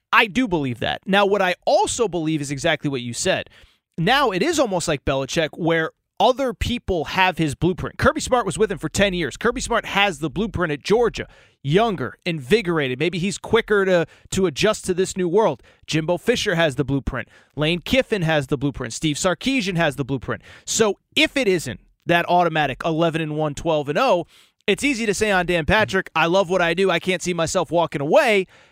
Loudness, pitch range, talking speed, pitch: -20 LUFS, 155-200 Hz, 205 wpm, 175 Hz